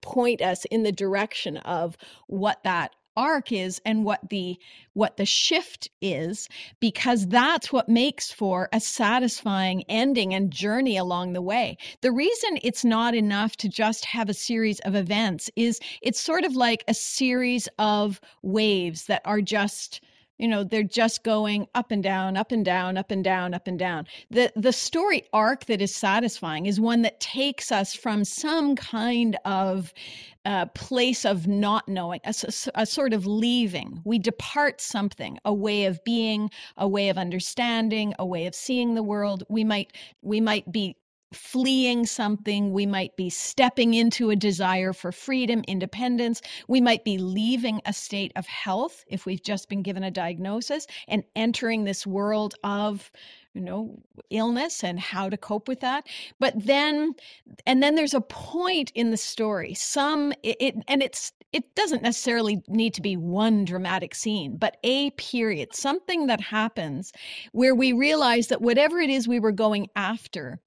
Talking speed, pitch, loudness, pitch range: 170 wpm, 220 Hz, -25 LUFS, 200-245 Hz